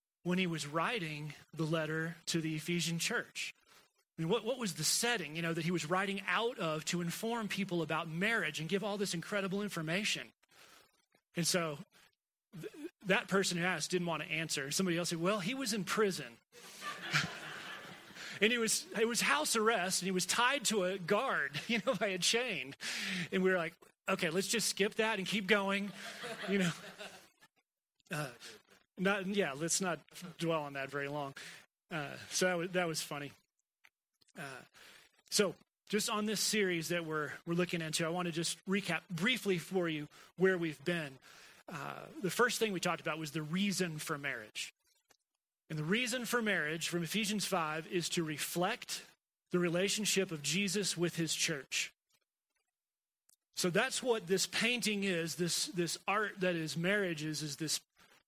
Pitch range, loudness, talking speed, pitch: 165-205 Hz, -35 LUFS, 175 wpm, 180 Hz